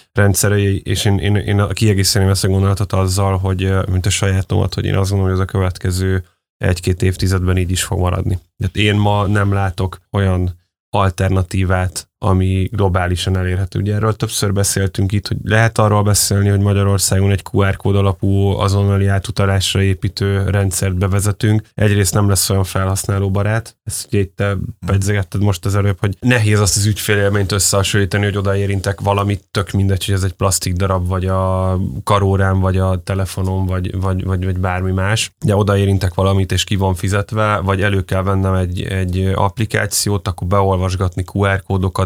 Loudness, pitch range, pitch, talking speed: -16 LUFS, 95-100 Hz, 100 Hz, 165 wpm